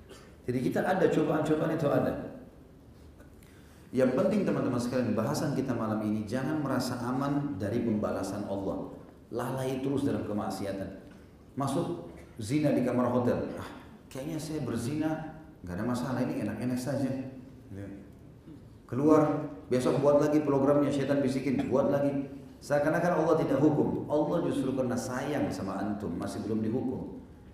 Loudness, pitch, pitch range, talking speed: -30 LUFS, 130 Hz, 110-145 Hz, 135 wpm